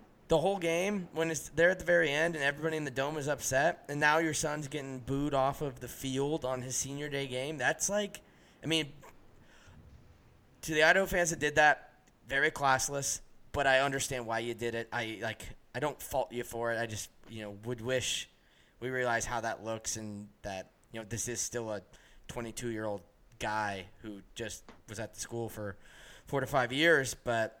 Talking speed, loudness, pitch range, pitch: 205 wpm, -32 LUFS, 115-150 Hz, 130 Hz